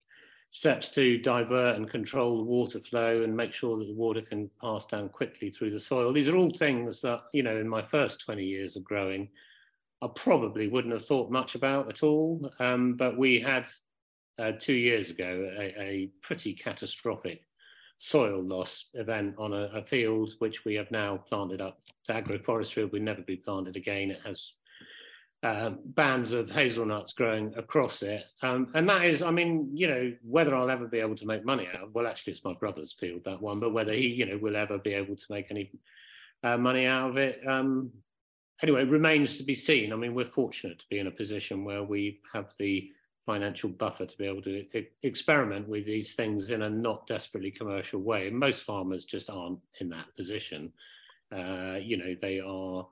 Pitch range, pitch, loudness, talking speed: 100-125 Hz, 110 Hz, -30 LUFS, 200 wpm